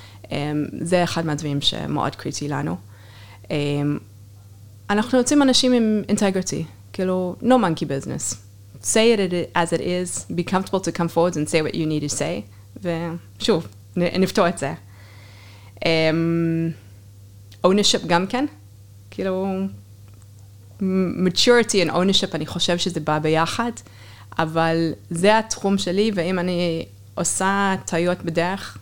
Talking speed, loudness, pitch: 125 wpm, -21 LUFS, 165 Hz